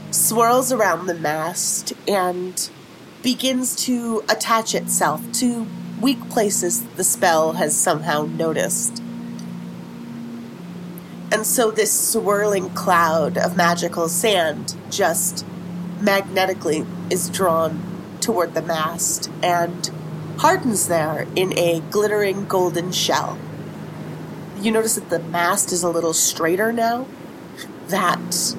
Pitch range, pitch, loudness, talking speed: 165-205 Hz, 180 Hz, -20 LUFS, 105 wpm